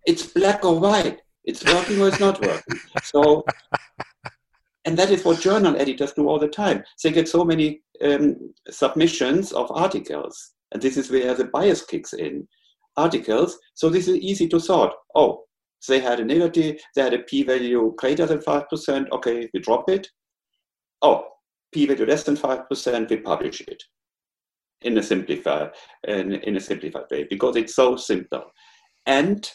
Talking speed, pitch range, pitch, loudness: 170 wpm, 145-200 Hz, 165 Hz, -21 LUFS